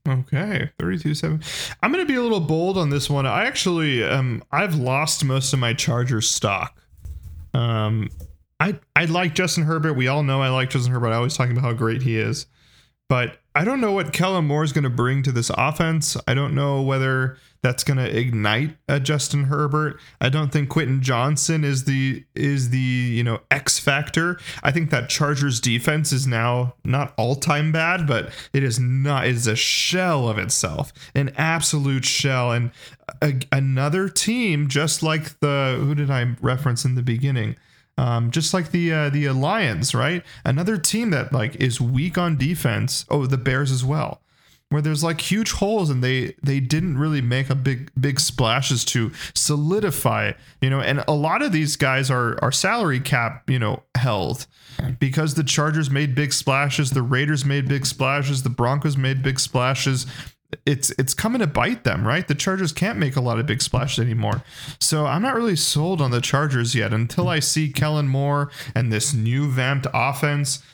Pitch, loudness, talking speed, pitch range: 140 Hz, -21 LUFS, 190 wpm, 130-155 Hz